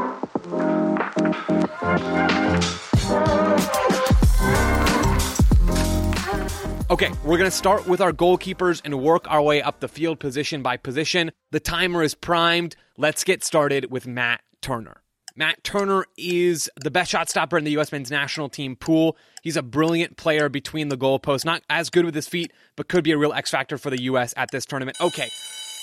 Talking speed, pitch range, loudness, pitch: 160 wpm, 140-170 Hz, -22 LUFS, 155 Hz